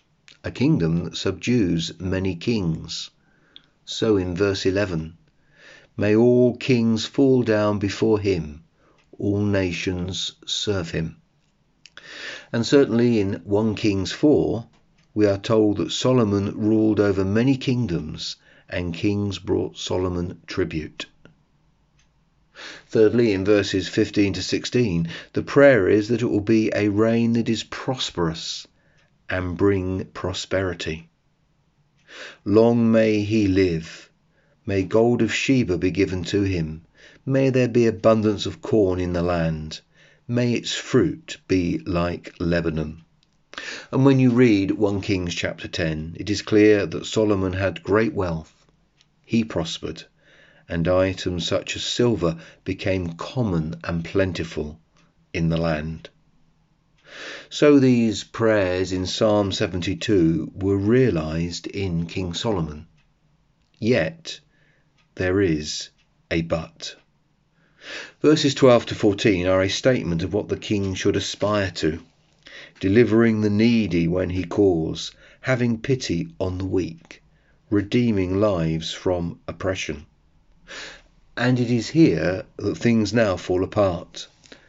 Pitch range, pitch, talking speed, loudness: 90-115 Hz, 100 Hz, 125 wpm, -22 LUFS